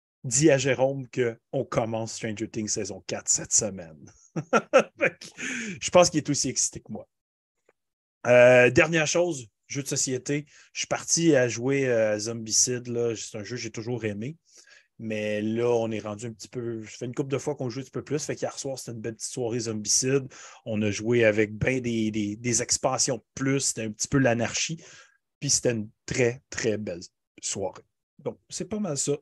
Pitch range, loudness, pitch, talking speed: 110-140 Hz, -26 LUFS, 125 Hz, 200 wpm